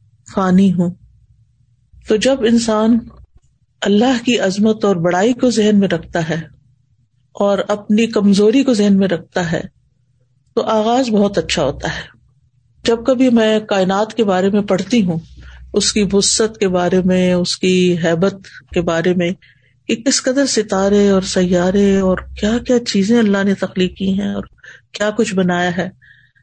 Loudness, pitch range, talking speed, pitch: -15 LUFS, 175-215 Hz, 160 wpm, 195 Hz